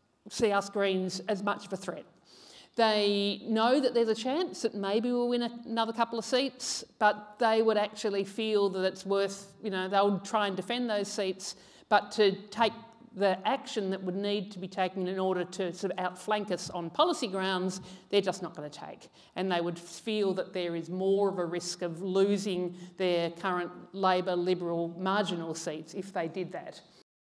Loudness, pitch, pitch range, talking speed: -31 LUFS, 195 Hz, 185-215 Hz, 195 wpm